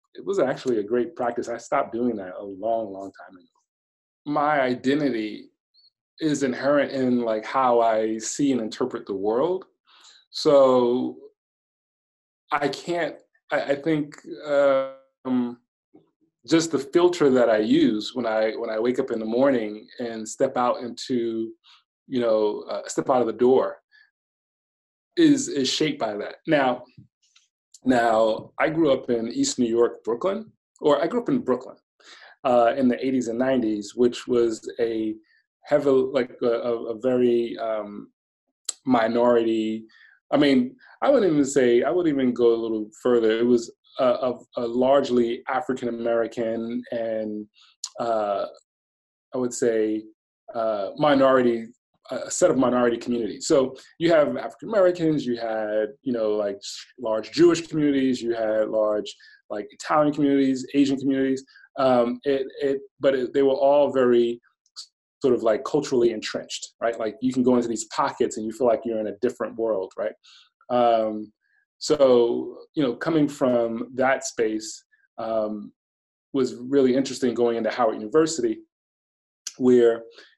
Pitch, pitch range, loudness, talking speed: 120 Hz, 115-140 Hz, -23 LUFS, 150 wpm